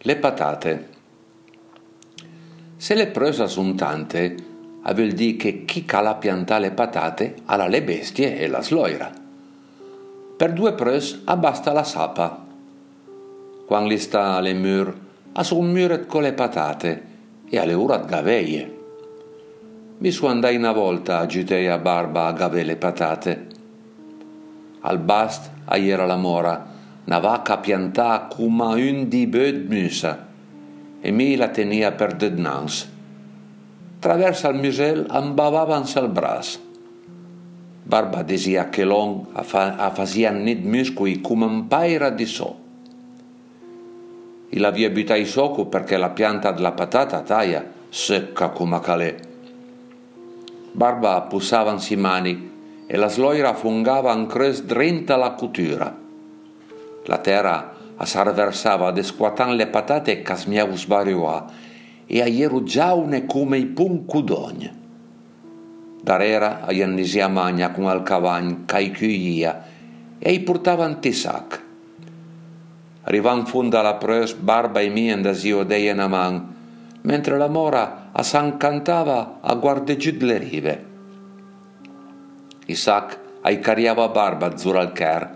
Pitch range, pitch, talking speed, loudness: 95-140 Hz, 110 Hz, 125 wpm, -21 LUFS